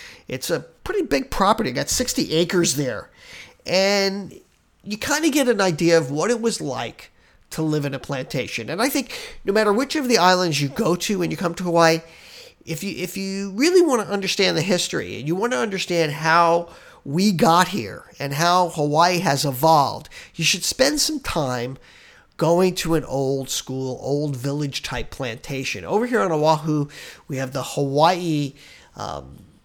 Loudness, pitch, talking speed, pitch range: -21 LUFS, 170 Hz, 185 wpm, 145-200 Hz